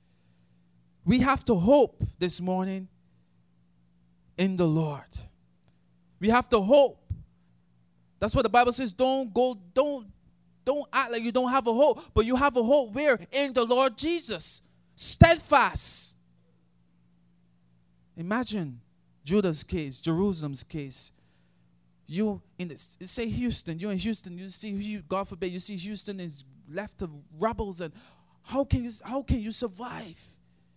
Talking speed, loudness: 140 wpm, -27 LUFS